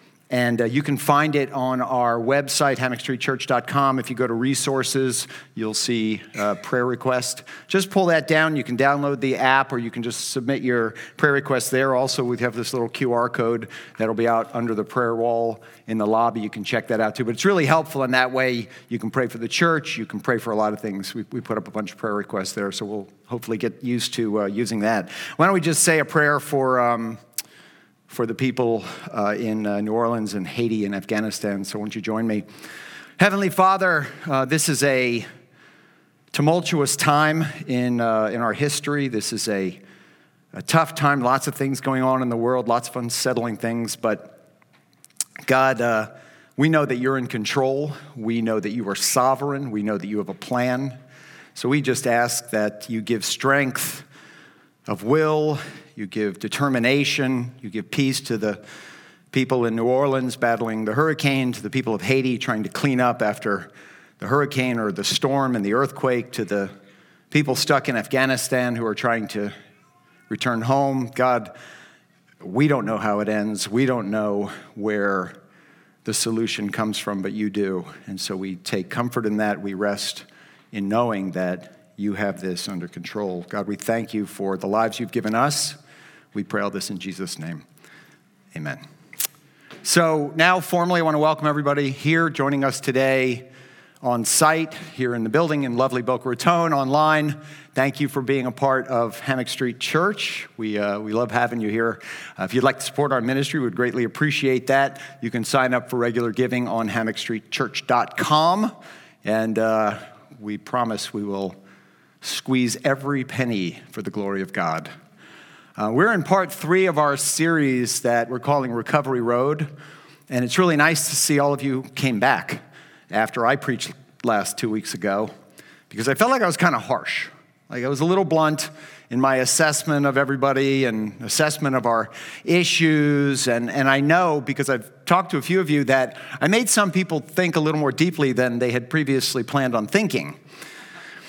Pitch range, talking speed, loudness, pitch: 110-145 Hz, 190 wpm, -22 LUFS, 125 Hz